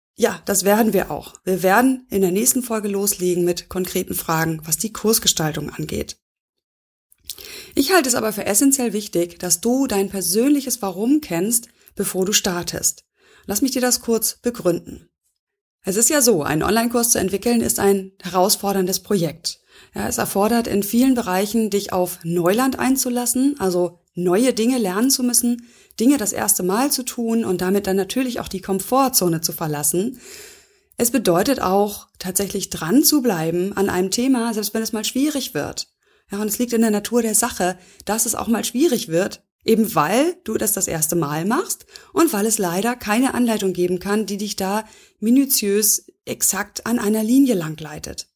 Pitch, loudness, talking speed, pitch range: 210 Hz, -19 LUFS, 170 wpm, 185-245 Hz